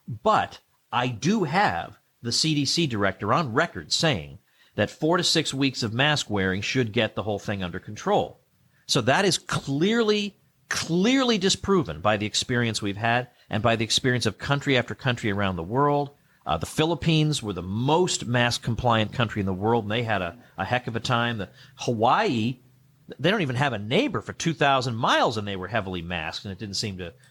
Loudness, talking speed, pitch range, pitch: -24 LUFS, 195 wpm, 110-145 Hz, 120 Hz